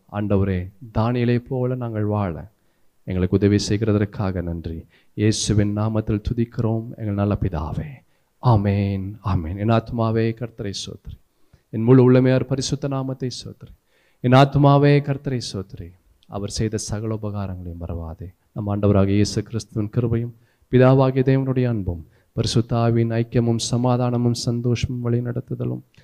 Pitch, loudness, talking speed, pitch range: 110 Hz, -21 LUFS, 115 wpm, 100-120 Hz